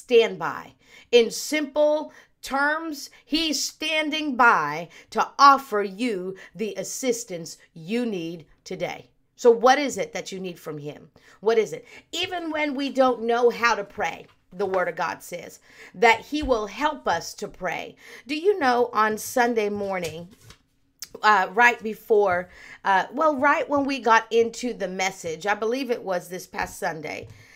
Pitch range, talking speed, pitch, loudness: 195-285 Hz, 160 wpm, 235 Hz, -23 LUFS